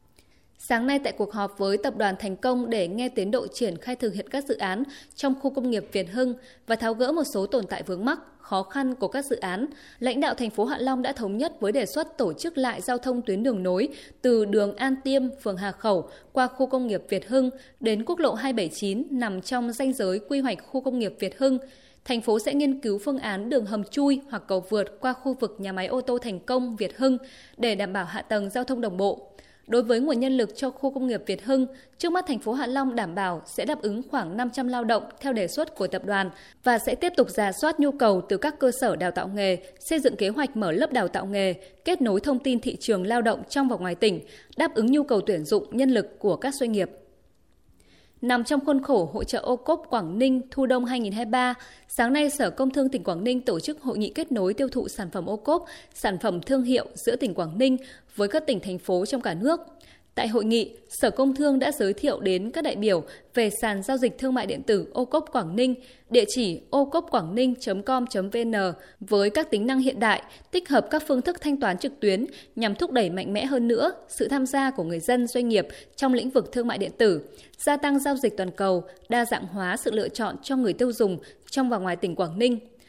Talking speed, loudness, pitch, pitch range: 250 wpm, -26 LUFS, 245 Hz, 205-265 Hz